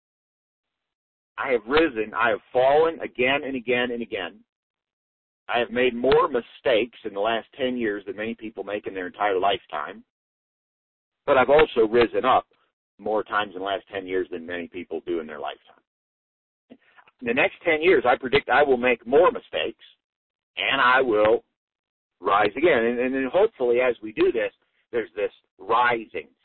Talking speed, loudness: 170 wpm, -23 LUFS